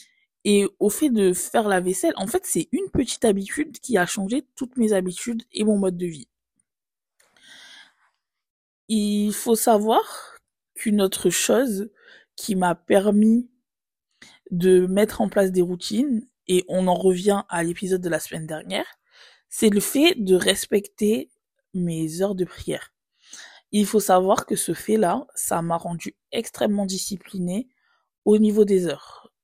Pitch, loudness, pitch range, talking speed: 205 Hz, -22 LUFS, 185-230 Hz, 150 wpm